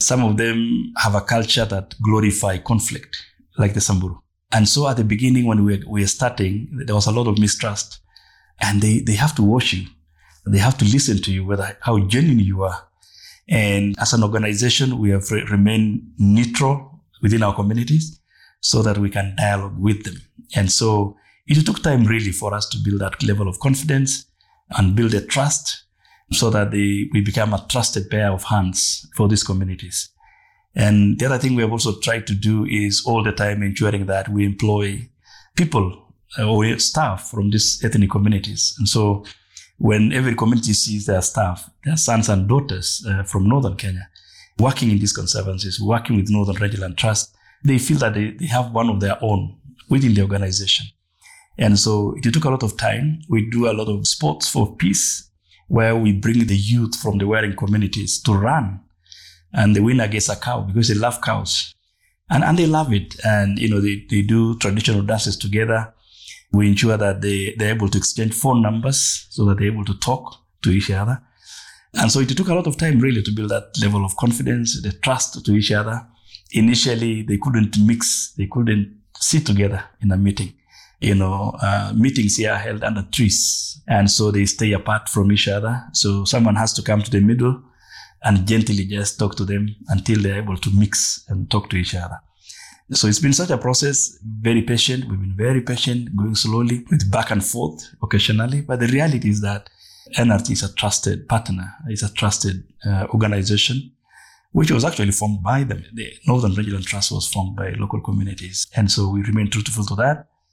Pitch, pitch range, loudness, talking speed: 105 Hz, 100-115 Hz, -19 LUFS, 195 wpm